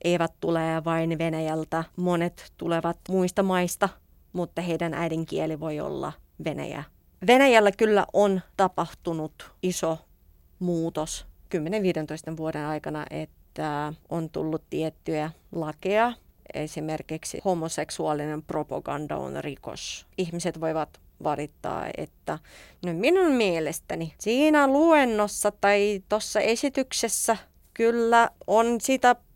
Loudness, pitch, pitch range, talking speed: -26 LUFS, 170 Hz, 160-210 Hz, 100 wpm